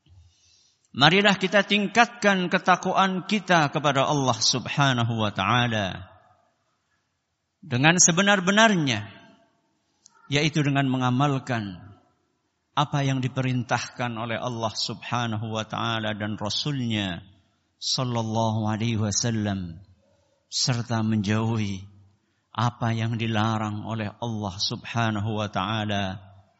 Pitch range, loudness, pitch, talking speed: 105-140 Hz, -24 LUFS, 115 Hz, 85 wpm